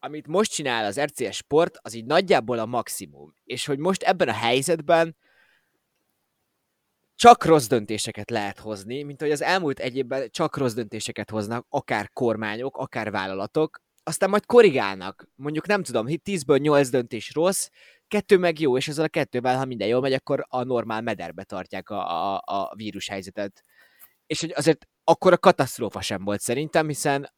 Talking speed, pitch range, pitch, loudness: 165 wpm, 110-160 Hz, 135 Hz, -23 LUFS